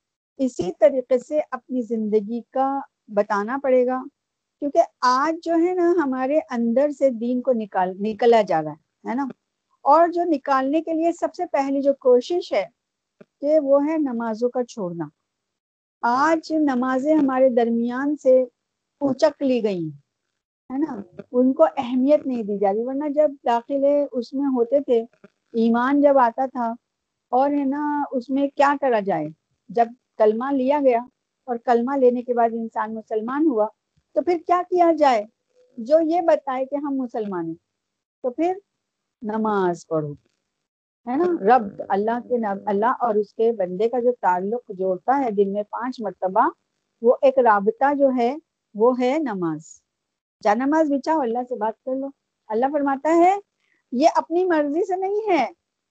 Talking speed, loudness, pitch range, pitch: 160 wpm, -21 LUFS, 230-295 Hz, 260 Hz